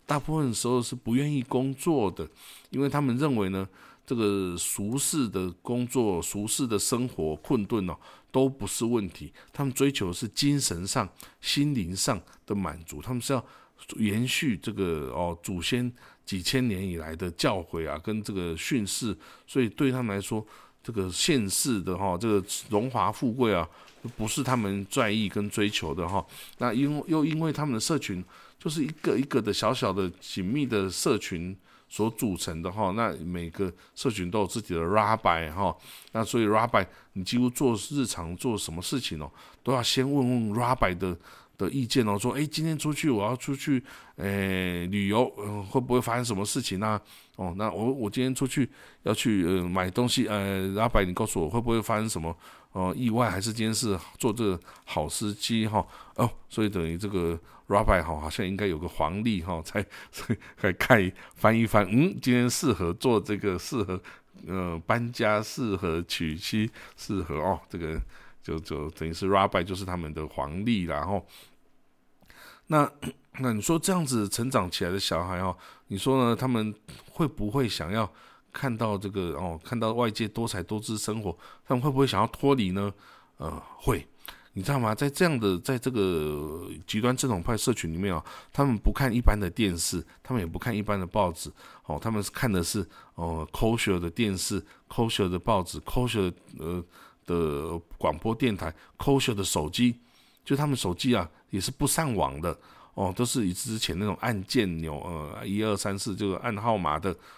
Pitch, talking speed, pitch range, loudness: 105 Hz, 275 characters per minute, 95-125 Hz, -28 LUFS